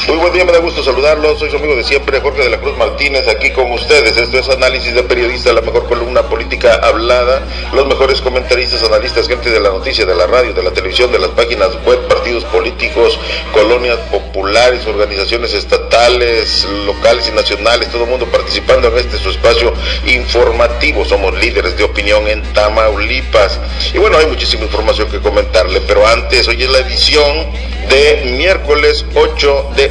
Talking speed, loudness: 180 wpm, -11 LUFS